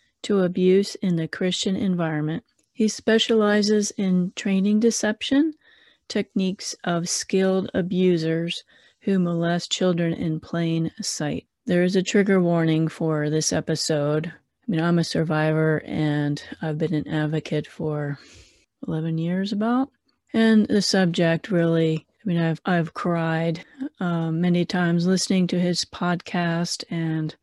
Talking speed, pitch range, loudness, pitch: 130 wpm, 160-200 Hz, -23 LUFS, 175 Hz